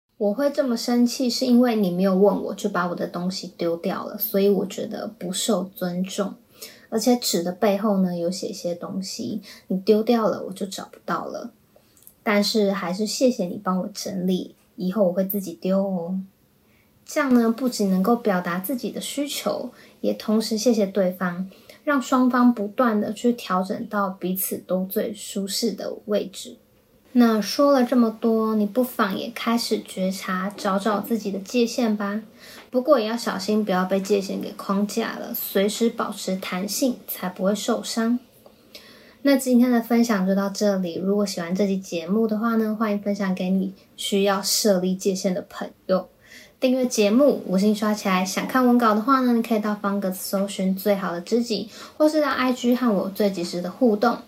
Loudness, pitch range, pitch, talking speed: -23 LUFS, 190-235 Hz, 210 Hz, 265 characters per minute